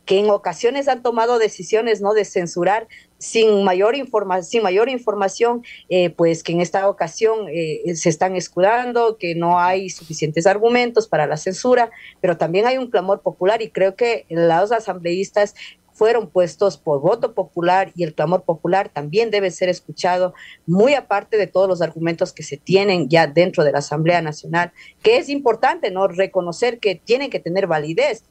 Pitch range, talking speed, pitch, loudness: 175-220 Hz, 175 wpm, 190 Hz, -18 LUFS